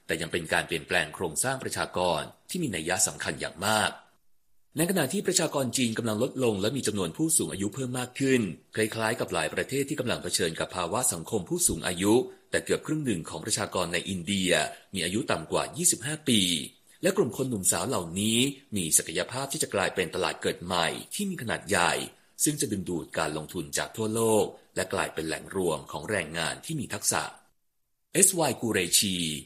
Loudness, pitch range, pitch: -27 LUFS, 100-145 Hz, 115 Hz